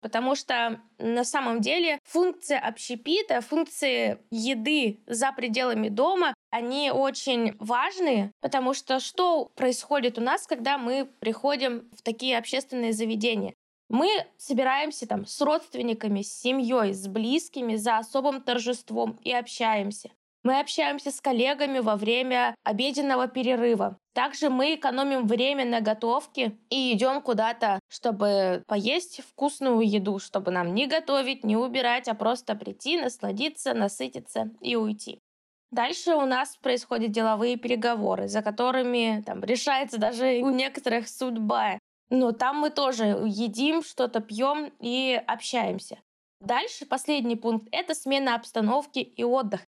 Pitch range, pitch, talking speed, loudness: 225-275 Hz, 250 Hz, 130 wpm, -27 LUFS